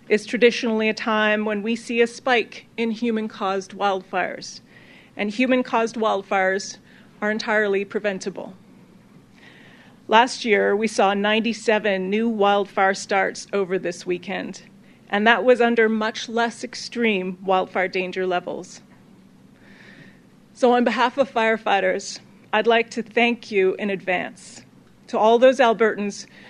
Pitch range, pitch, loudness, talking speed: 195-230 Hz, 215 Hz, -21 LUFS, 130 wpm